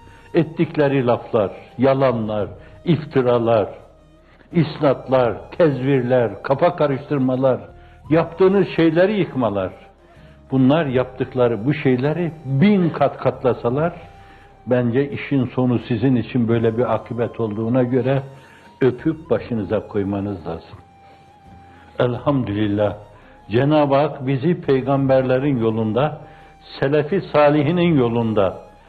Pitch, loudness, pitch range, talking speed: 130 Hz, -19 LUFS, 110-150 Hz, 85 wpm